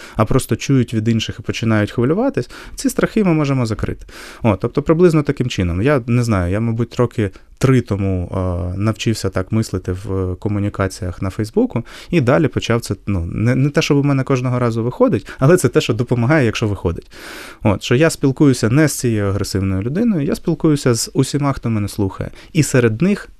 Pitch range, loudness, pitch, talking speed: 105-140 Hz, -17 LUFS, 120 Hz, 185 wpm